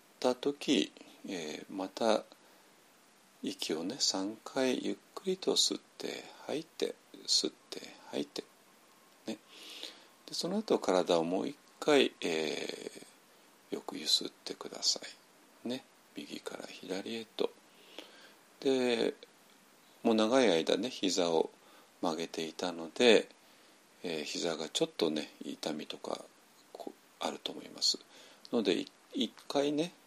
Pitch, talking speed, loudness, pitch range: 135 Hz, 195 characters per minute, -34 LUFS, 115-185 Hz